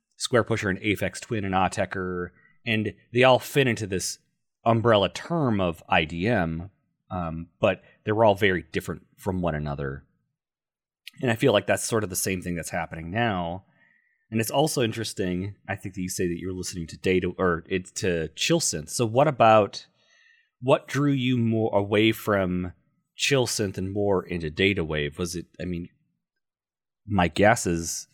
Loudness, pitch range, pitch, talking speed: -25 LUFS, 90-115 Hz, 95 Hz, 170 wpm